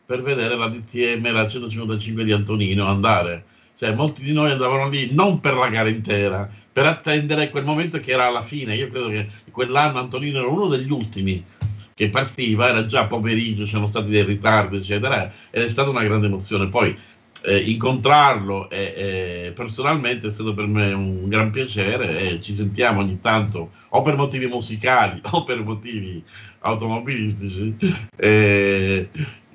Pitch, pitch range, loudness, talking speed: 110 Hz, 105-130 Hz, -20 LUFS, 160 wpm